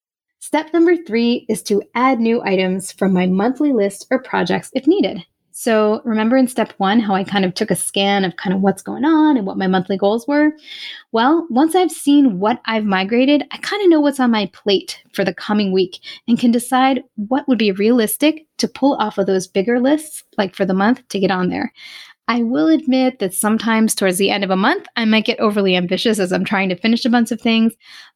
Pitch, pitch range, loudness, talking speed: 230 Hz, 200-265 Hz, -17 LUFS, 225 wpm